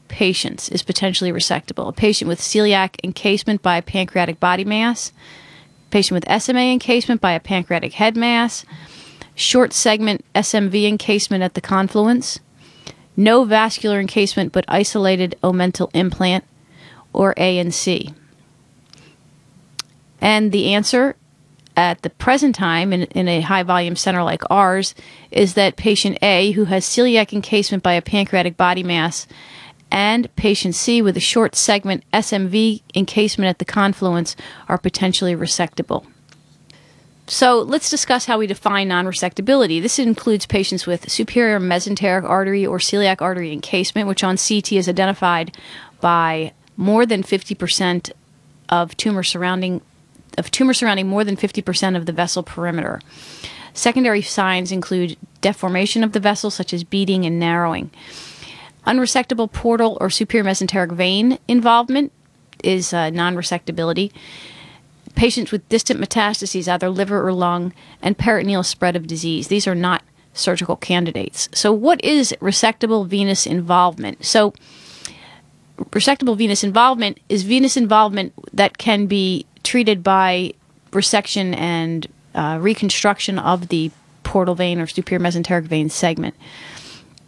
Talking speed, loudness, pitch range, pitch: 135 wpm, -17 LUFS, 175-210 Hz, 190 Hz